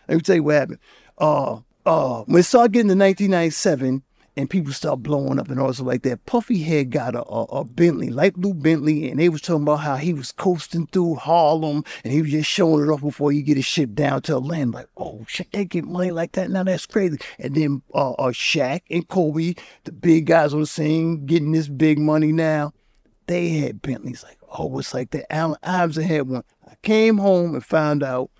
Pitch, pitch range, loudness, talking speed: 160 Hz, 145-175 Hz, -20 LUFS, 220 wpm